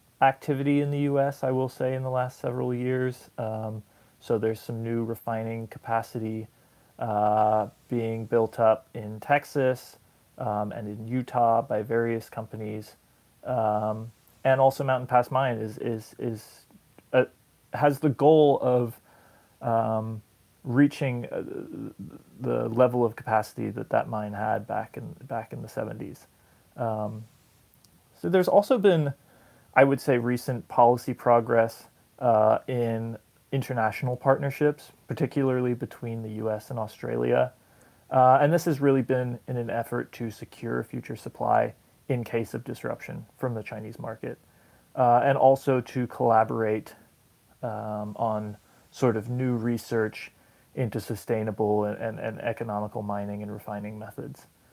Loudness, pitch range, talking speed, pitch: -27 LUFS, 110-130 Hz, 140 wpm, 120 Hz